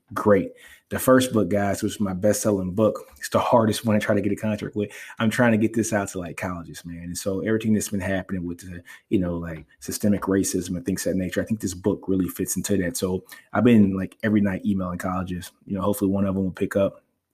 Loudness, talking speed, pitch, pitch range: -24 LUFS, 255 wpm, 100 Hz, 90-105 Hz